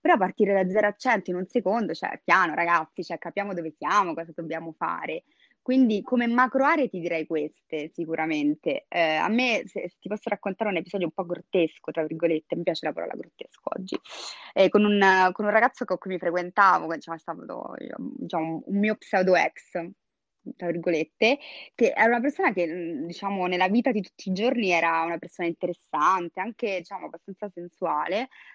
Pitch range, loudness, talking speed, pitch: 170-215 Hz, -25 LUFS, 185 wpm, 185 Hz